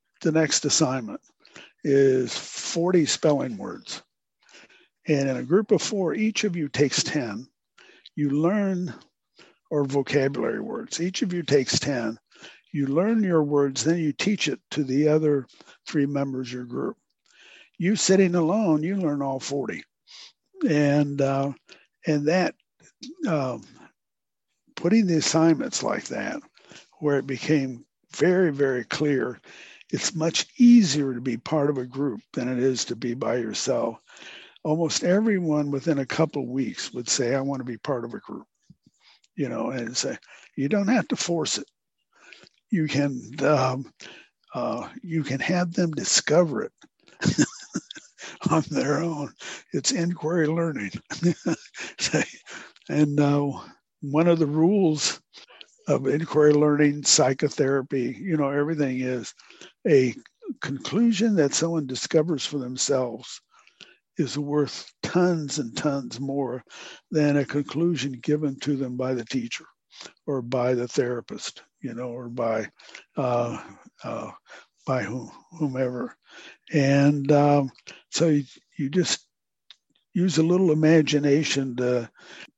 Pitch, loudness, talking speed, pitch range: 145 Hz, -24 LUFS, 135 wpm, 135-165 Hz